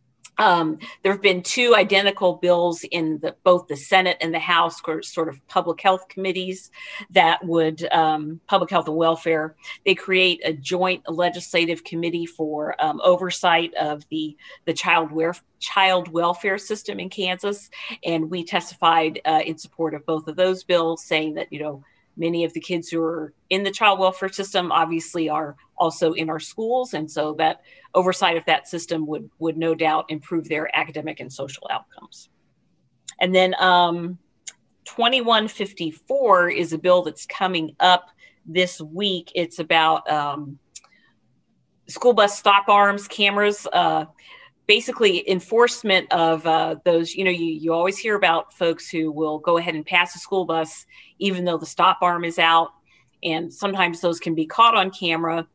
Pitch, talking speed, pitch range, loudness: 170 Hz, 165 wpm, 160-185 Hz, -21 LUFS